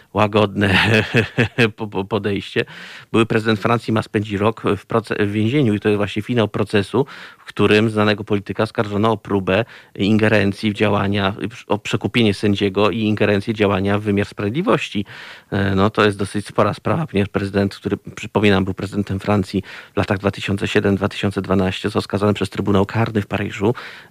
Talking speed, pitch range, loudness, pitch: 145 wpm, 100-110 Hz, -19 LUFS, 105 Hz